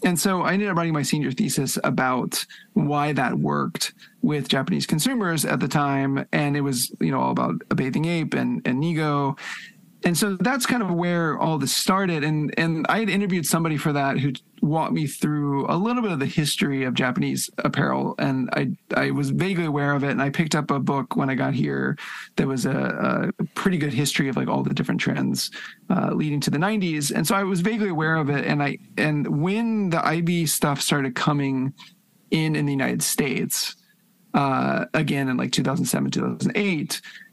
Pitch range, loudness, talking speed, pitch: 140-190 Hz, -23 LUFS, 205 wpm, 160 Hz